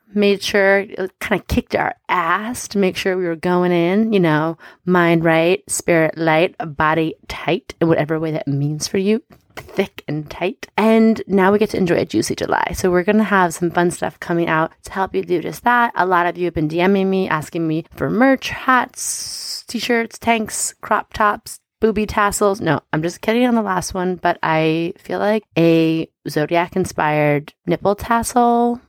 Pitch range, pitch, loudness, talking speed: 165-205 Hz, 180 Hz, -18 LUFS, 195 wpm